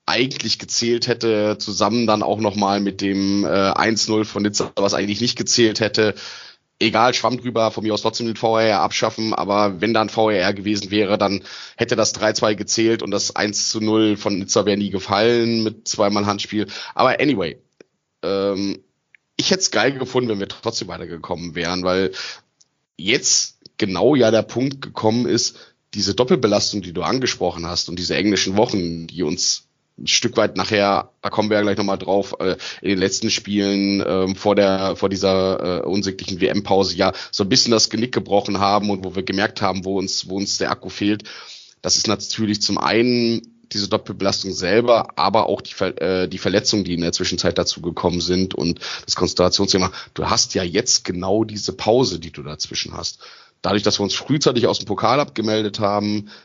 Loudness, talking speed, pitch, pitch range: -19 LUFS, 180 wpm, 100 Hz, 95-110 Hz